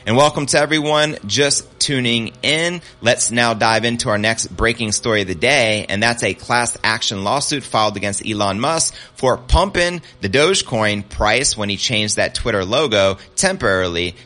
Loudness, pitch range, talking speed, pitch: -17 LUFS, 105-135 Hz, 170 wpm, 115 Hz